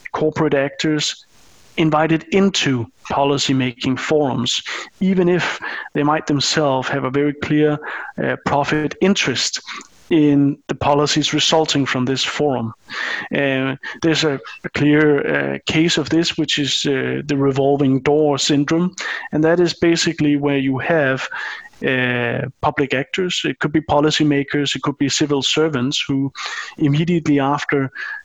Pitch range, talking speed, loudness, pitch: 135-155 Hz, 135 wpm, -18 LUFS, 145 Hz